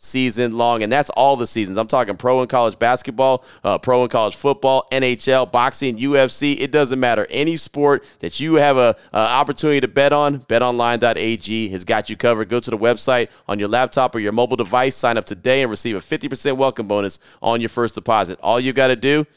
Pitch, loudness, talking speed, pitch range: 125 Hz, -18 LUFS, 215 wpm, 115-135 Hz